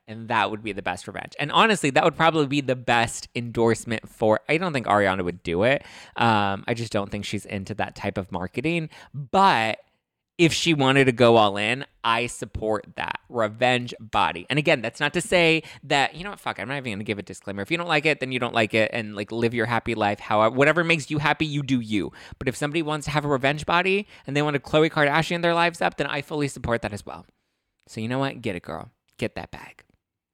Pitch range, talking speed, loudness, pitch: 110-150 Hz, 250 wpm, -23 LUFS, 125 Hz